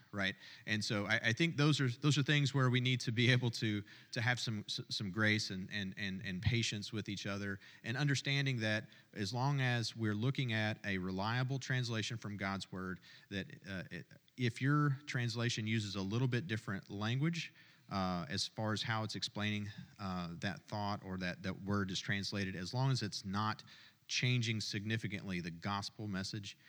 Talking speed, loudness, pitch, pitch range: 185 wpm, -37 LUFS, 110 Hz, 100-125 Hz